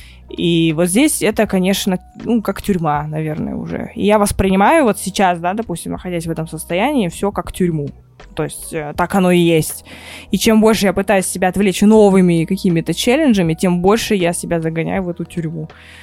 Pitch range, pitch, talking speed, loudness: 165-205 Hz, 185 Hz, 180 wpm, -16 LUFS